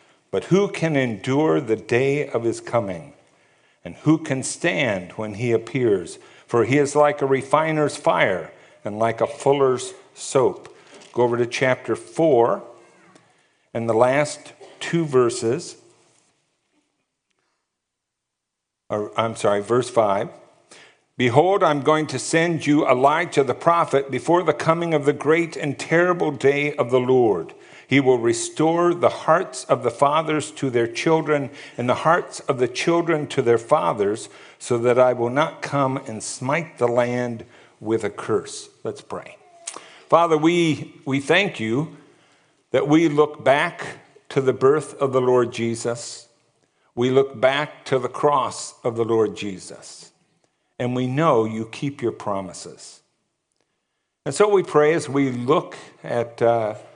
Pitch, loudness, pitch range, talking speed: 135 Hz, -21 LUFS, 120-155 Hz, 150 wpm